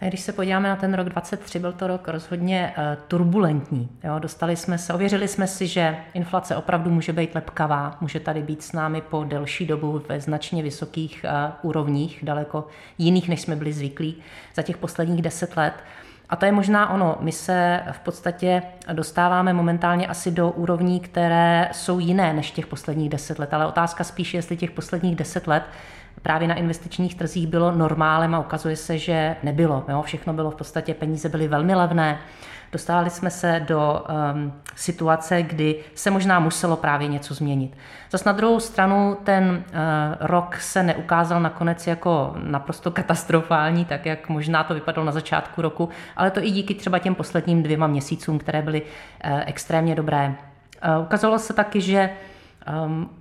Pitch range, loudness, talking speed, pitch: 155-175 Hz, -23 LUFS, 175 wpm, 165 Hz